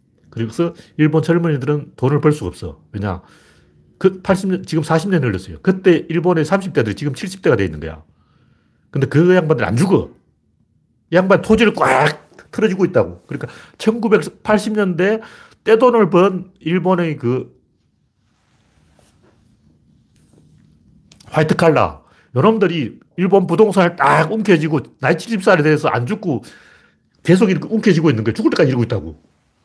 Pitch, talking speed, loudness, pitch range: 160 Hz, 270 characters per minute, -16 LUFS, 120-190 Hz